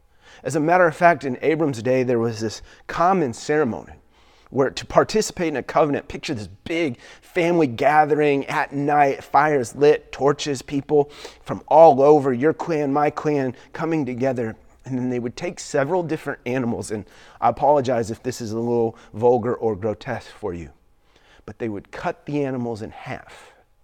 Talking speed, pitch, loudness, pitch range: 170 wpm, 135 Hz, -21 LUFS, 115-150 Hz